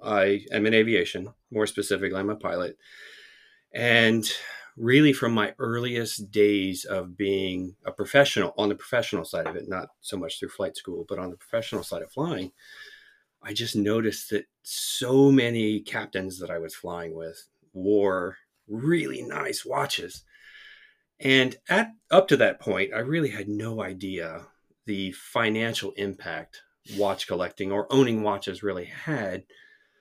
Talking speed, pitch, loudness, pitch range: 150 wpm, 110 Hz, -26 LUFS, 100-135 Hz